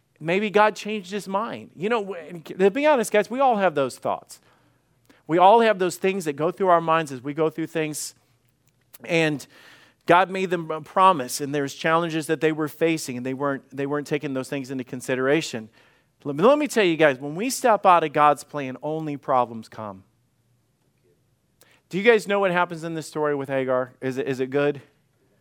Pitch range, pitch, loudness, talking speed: 135-180 Hz, 155 Hz, -22 LUFS, 205 wpm